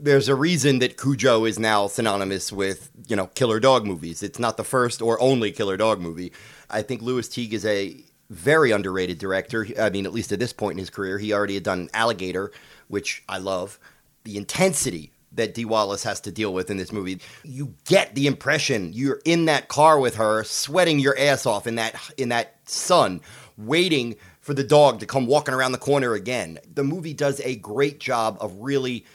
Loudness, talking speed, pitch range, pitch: -22 LUFS, 205 wpm, 105-140 Hz, 115 Hz